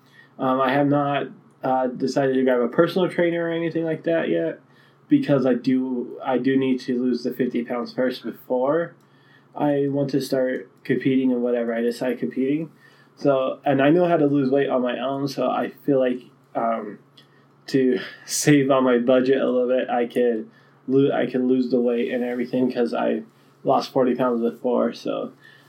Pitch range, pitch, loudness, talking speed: 125-140 Hz, 130 Hz, -22 LUFS, 185 wpm